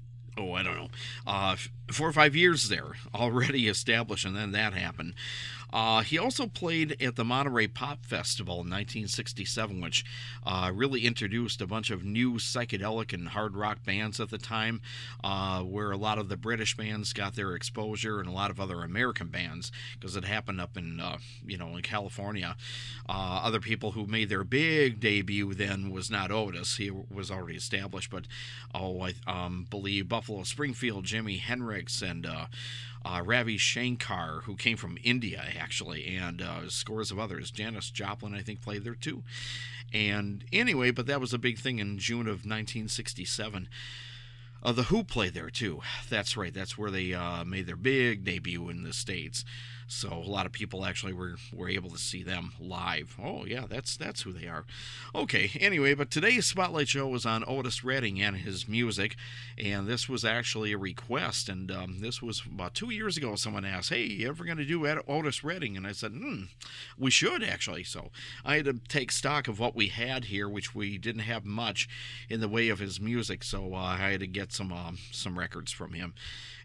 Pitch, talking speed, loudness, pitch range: 110 Hz, 195 wpm, -31 LUFS, 100-120 Hz